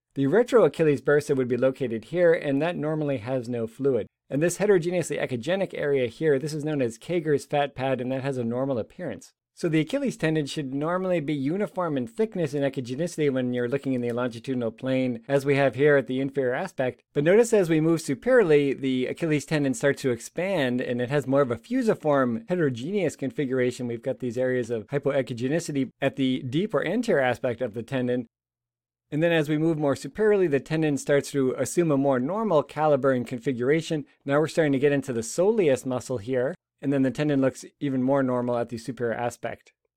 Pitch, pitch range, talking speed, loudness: 140 Hz, 125-155 Hz, 205 wpm, -25 LUFS